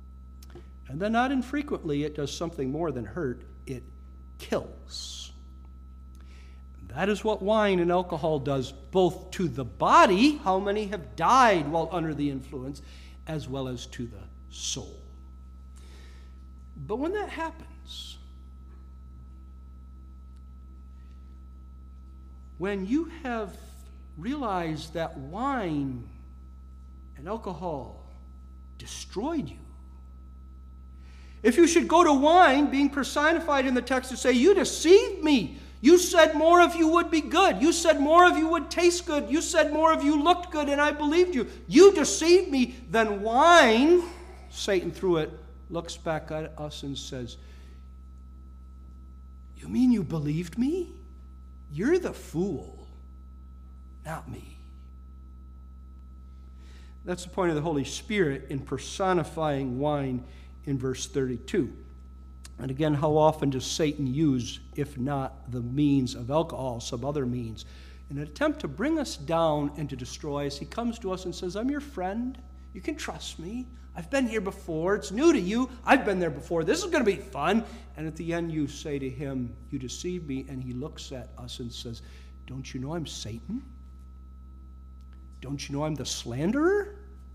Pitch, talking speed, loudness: 140 Hz, 150 wpm, -26 LUFS